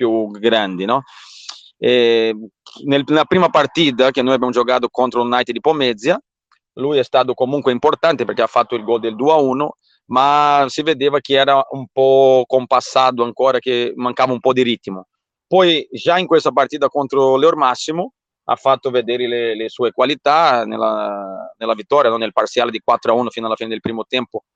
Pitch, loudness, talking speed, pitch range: 130 Hz, -16 LUFS, 180 wpm, 115-140 Hz